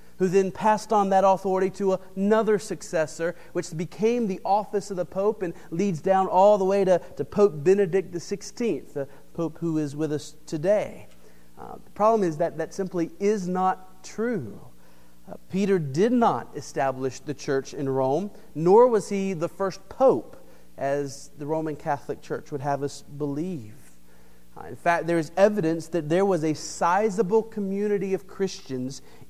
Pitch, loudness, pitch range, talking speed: 180 Hz, -25 LUFS, 150-200 Hz, 170 wpm